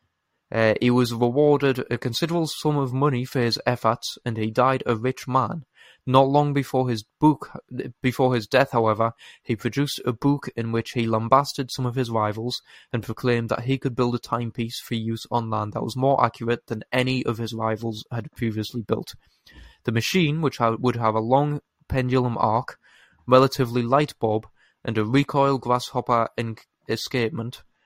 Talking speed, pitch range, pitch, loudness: 175 wpm, 115-135 Hz, 125 Hz, -23 LUFS